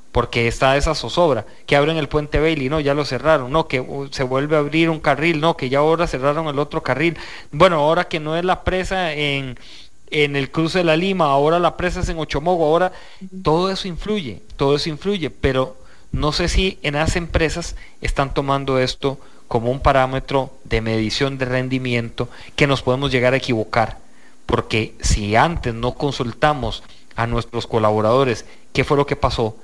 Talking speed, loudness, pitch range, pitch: 185 wpm, -19 LUFS, 130-160 Hz, 140 Hz